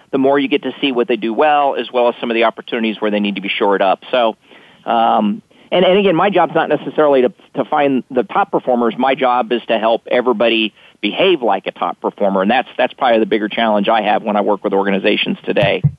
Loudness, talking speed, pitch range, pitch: -15 LUFS, 245 wpm, 115-145 Hz, 125 Hz